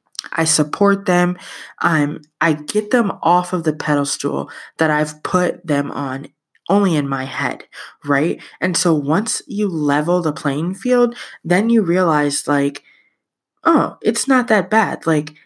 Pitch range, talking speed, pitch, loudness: 150-195 Hz, 155 wpm, 165 Hz, -17 LUFS